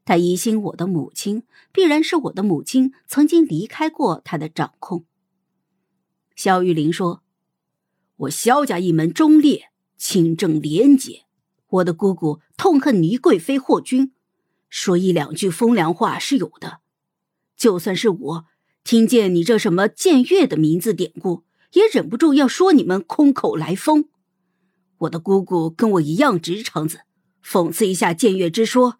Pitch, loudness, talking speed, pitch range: 190 Hz, -18 LUFS, 220 characters per minute, 175-260 Hz